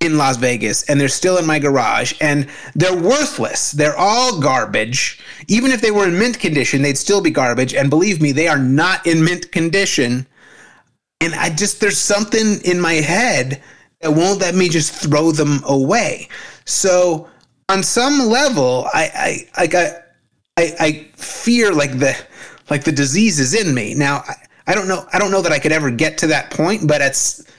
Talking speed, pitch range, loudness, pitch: 190 wpm, 145-195 Hz, -15 LUFS, 165 Hz